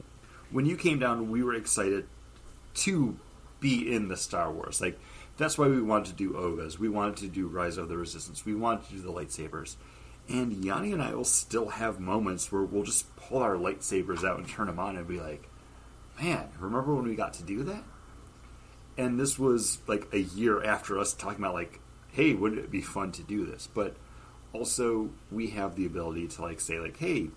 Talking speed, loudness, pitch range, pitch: 210 wpm, -31 LUFS, 90-115 Hz, 100 Hz